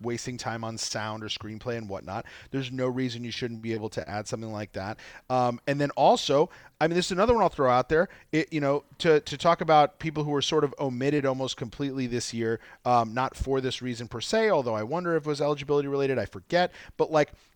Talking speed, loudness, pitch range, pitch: 240 wpm, -27 LUFS, 115-150 Hz, 130 Hz